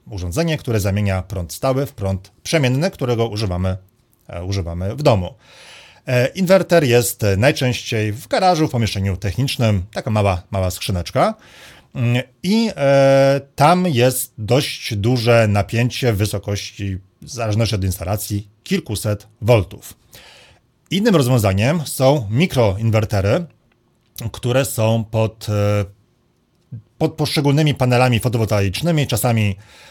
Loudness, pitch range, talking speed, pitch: -18 LUFS, 100-135 Hz, 100 wpm, 115 Hz